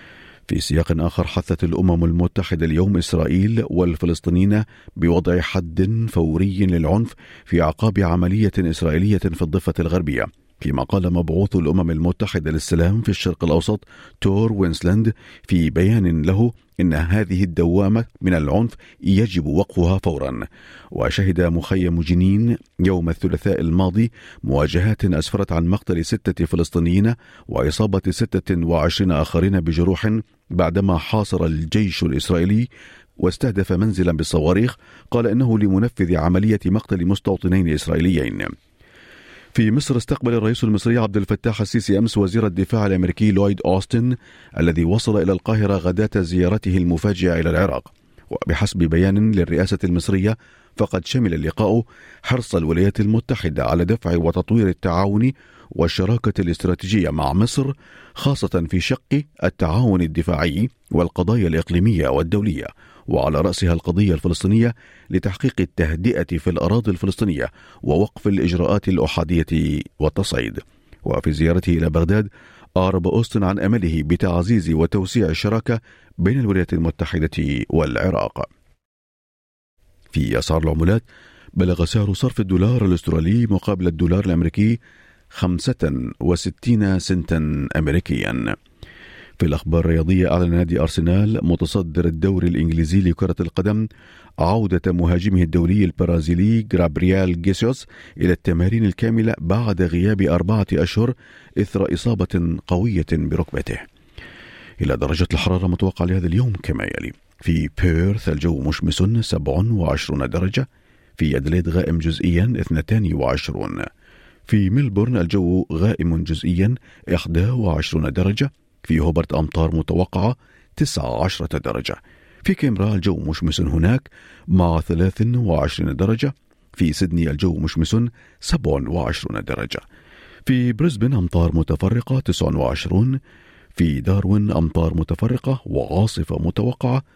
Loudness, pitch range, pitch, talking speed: -20 LUFS, 85-105 Hz, 90 Hz, 110 wpm